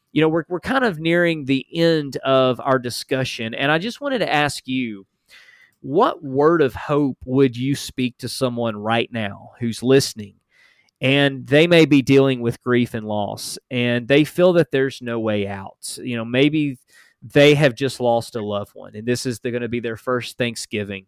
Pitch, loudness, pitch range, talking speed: 130 Hz, -20 LUFS, 115-145 Hz, 195 wpm